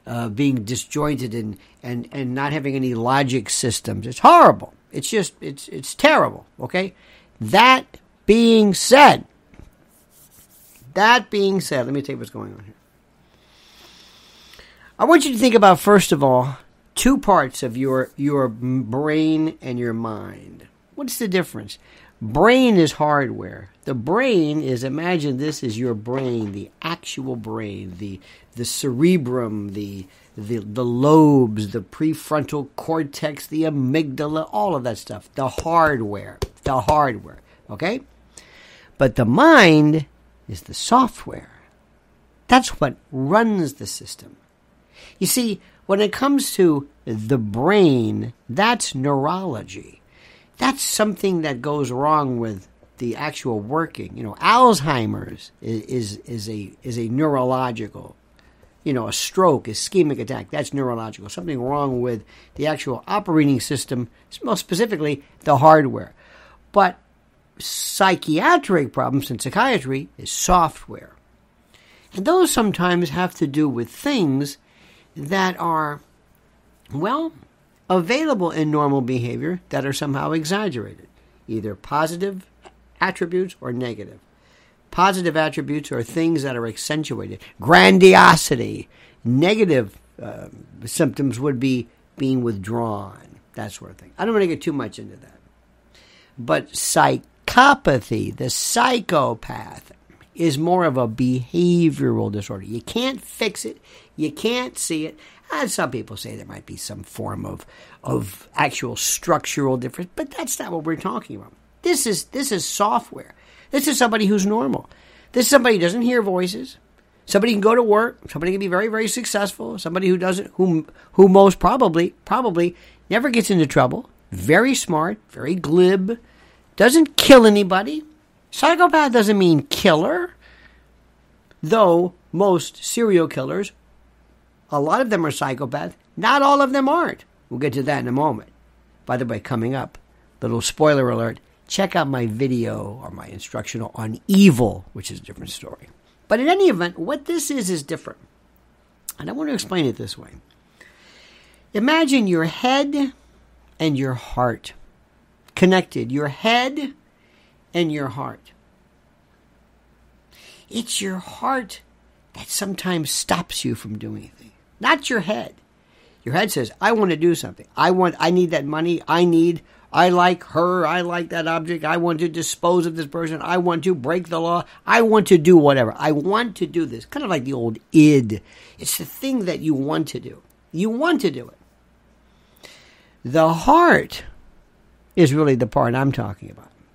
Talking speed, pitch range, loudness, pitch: 145 wpm, 125-190 Hz, -19 LUFS, 155 Hz